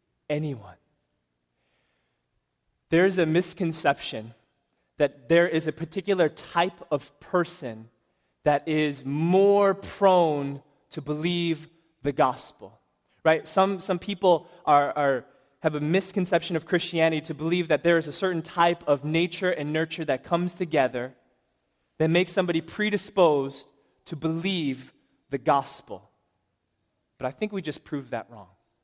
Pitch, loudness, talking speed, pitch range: 160 Hz, -25 LUFS, 130 wpm, 140-175 Hz